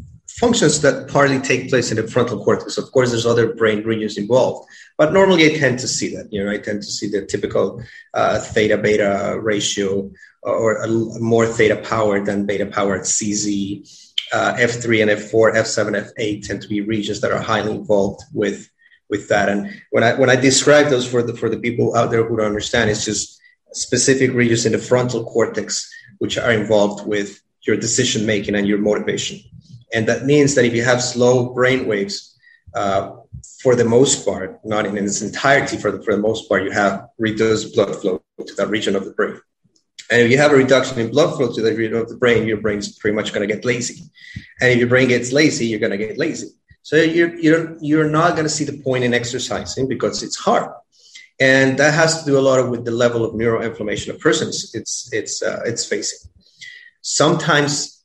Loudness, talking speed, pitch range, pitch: -17 LUFS, 210 wpm, 110-140 Hz, 120 Hz